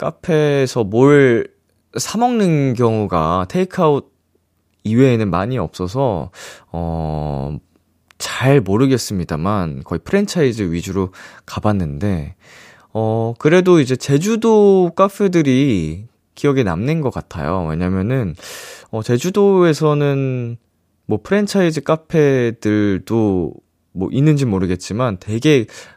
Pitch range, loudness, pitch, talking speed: 95-150 Hz, -16 LUFS, 120 Hz, 235 characters per minute